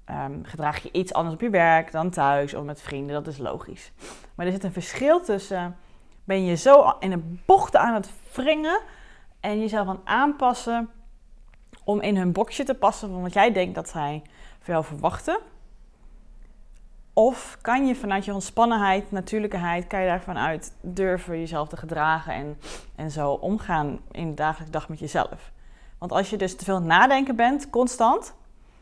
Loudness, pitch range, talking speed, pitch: -24 LUFS, 160-220 Hz, 175 wpm, 185 Hz